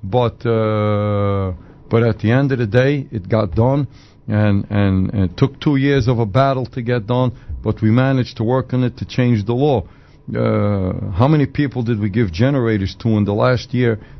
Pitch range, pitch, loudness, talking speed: 105-130 Hz, 115 Hz, -17 LUFS, 205 wpm